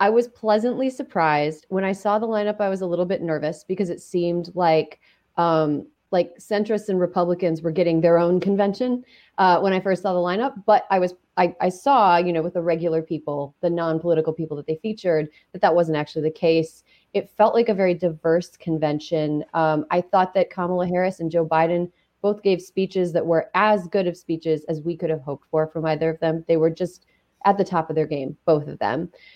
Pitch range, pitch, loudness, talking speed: 160-195 Hz, 175 Hz, -22 LUFS, 220 wpm